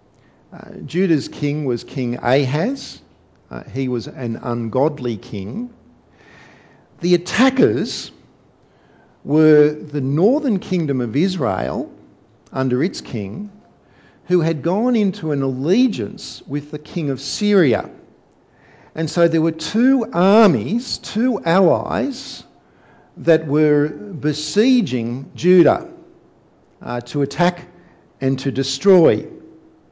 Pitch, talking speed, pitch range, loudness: 155 Hz, 105 wpm, 135-195 Hz, -18 LUFS